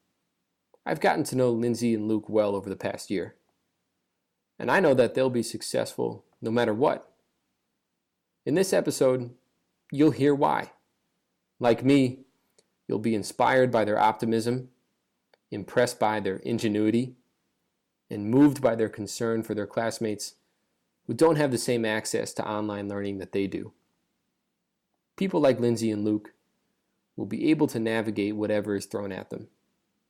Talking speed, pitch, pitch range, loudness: 150 wpm, 115 Hz, 105-125 Hz, -26 LUFS